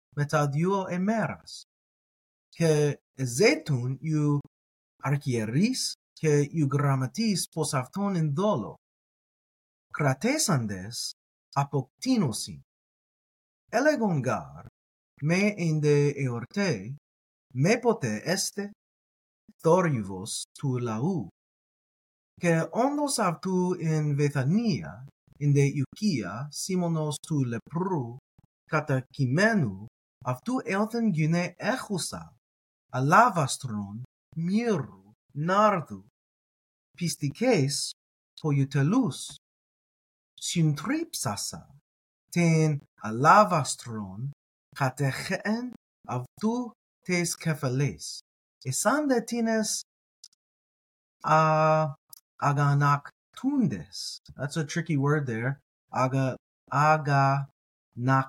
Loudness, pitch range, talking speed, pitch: -27 LUFS, 130-185 Hz, 75 wpm, 150 Hz